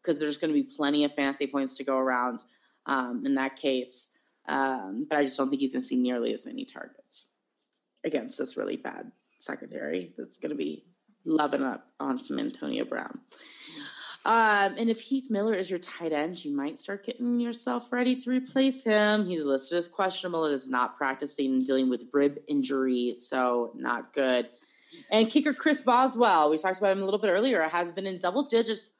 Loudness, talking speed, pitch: -27 LUFS, 200 wpm, 180 Hz